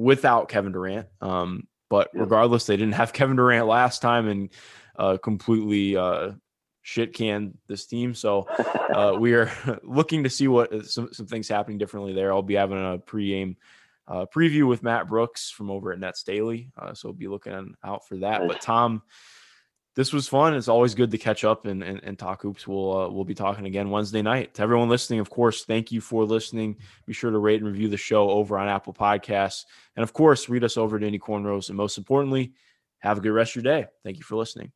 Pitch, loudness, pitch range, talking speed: 110 Hz, -24 LUFS, 100-120 Hz, 215 wpm